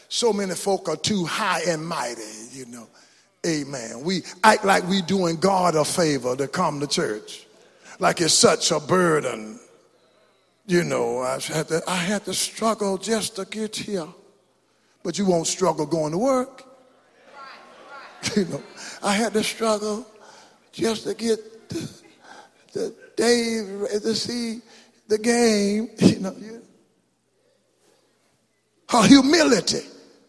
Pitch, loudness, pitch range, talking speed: 195 Hz, -22 LUFS, 165-225 Hz, 135 wpm